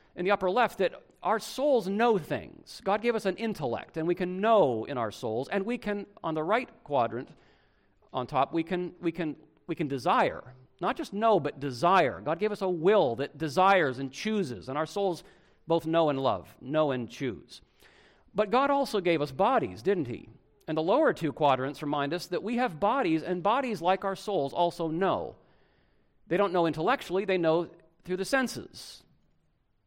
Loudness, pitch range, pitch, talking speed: -29 LUFS, 155-205 Hz, 180 Hz, 195 wpm